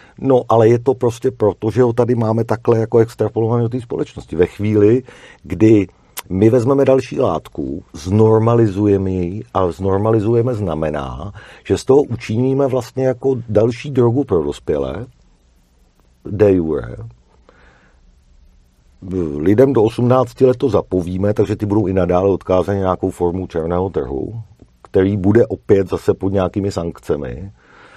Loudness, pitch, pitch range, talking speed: -16 LUFS, 105 Hz, 90-120 Hz, 135 wpm